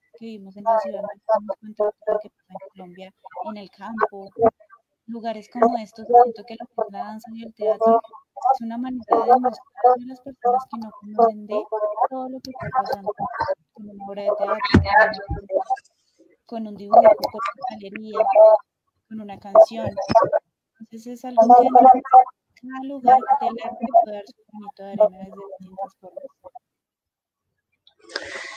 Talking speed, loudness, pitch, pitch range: 150 wpm, -19 LUFS, 225 Hz, 210-255 Hz